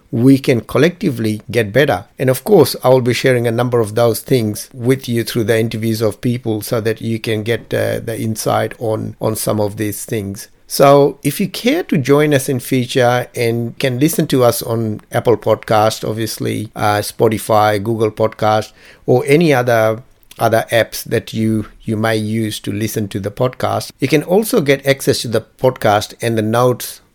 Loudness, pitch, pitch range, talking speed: -15 LUFS, 115 Hz, 110-130 Hz, 190 wpm